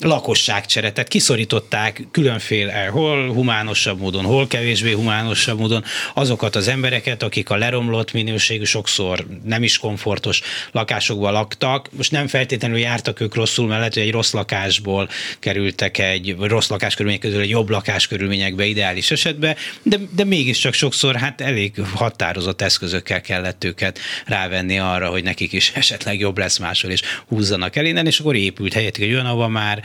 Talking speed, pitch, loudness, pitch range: 150 wpm, 110 Hz, -18 LUFS, 100-125 Hz